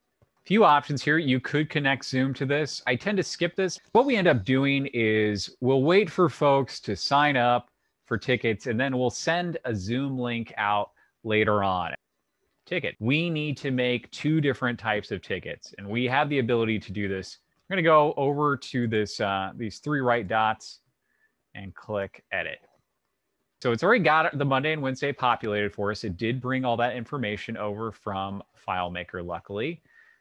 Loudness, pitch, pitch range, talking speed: -26 LUFS, 125 Hz, 110-145 Hz, 185 wpm